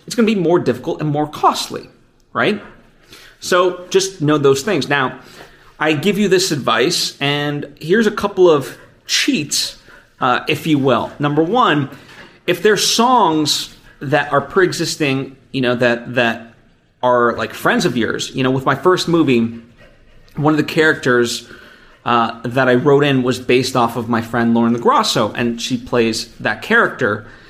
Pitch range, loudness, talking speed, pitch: 120-165 Hz, -16 LUFS, 165 wpm, 140 Hz